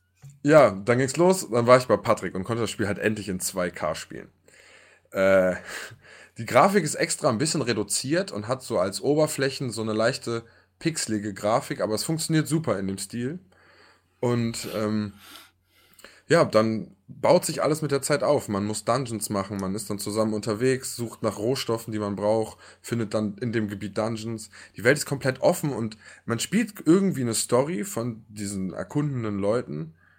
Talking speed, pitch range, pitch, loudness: 180 wpm, 105-135 Hz, 115 Hz, -25 LUFS